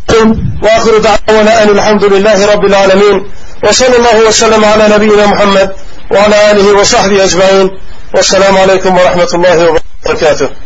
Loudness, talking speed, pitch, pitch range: -6 LUFS, 125 wpm, 205 Hz, 195-215 Hz